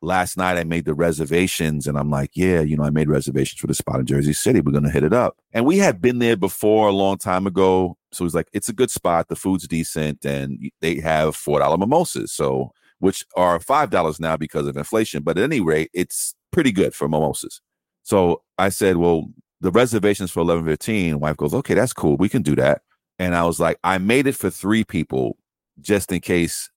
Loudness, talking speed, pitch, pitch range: -20 LUFS, 225 wpm, 85 Hz, 75-95 Hz